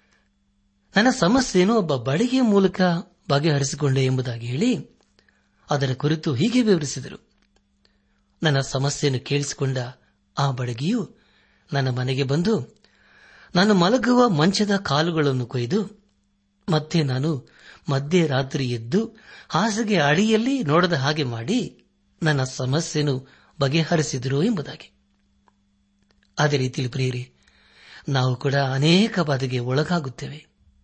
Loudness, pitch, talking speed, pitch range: -22 LUFS, 145 Hz, 90 wpm, 130-175 Hz